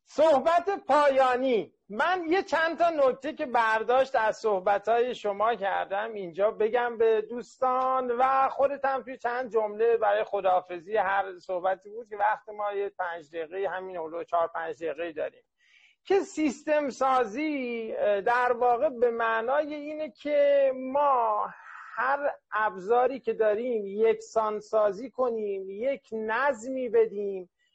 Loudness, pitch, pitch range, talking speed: -27 LUFS, 240 Hz, 210-275 Hz, 130 wpm